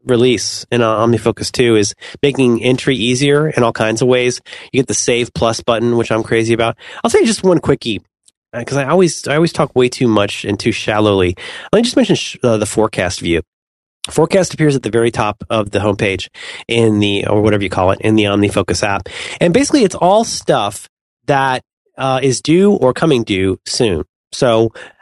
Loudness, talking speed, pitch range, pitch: -14 LUFS, 200 wpm, 105-135 Hz, 115 Hz